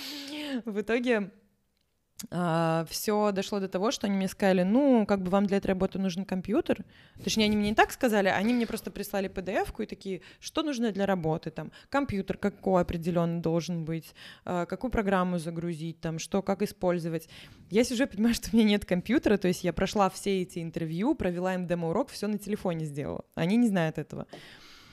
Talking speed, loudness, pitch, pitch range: 185 wpm, -29 LUFS, 195 Hz, 175-215 Hz